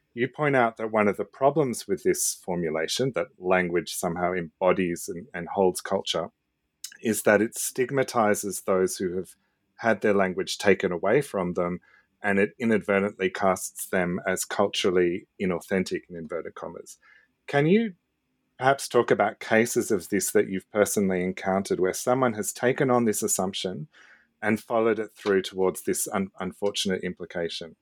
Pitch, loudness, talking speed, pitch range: 100 Hz, -26 LUFS, 155 wpm, 90-115 Hz